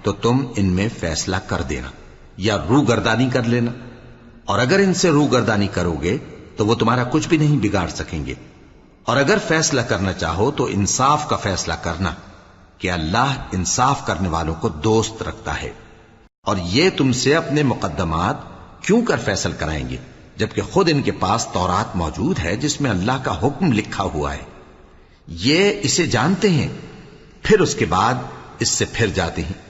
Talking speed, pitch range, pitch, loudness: 180 wpm, 85-130 Hz, 105 Hz, -19 LUFS